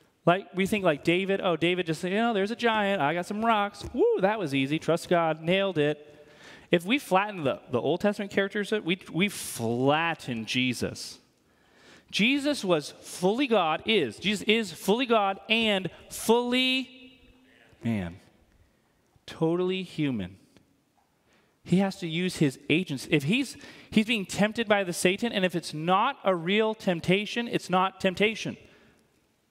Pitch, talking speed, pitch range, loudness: 185 Hz, 155 wpm, 160-210 Hz, -27 LUFS